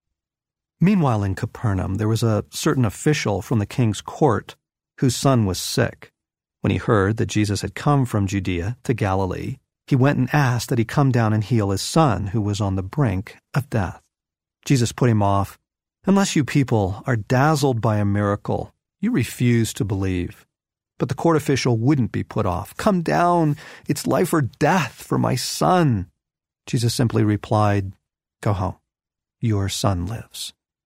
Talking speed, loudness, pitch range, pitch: 170 wpm, -21 LUFS, 100-135 Hz, 115 Hz